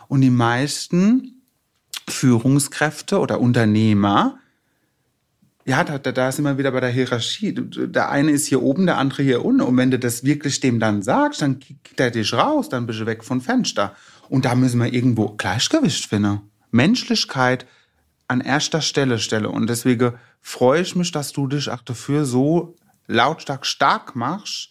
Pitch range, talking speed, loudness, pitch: 120-150 Hz, 170 wpm, -19 LUFS, 130 Hz